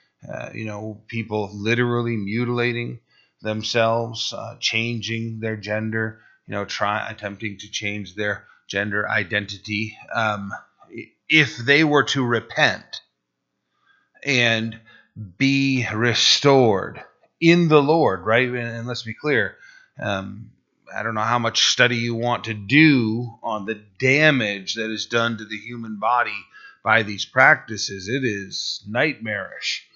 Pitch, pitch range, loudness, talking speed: 115 Hz, 105-120 Hz, -21 LUFS, 130 wpm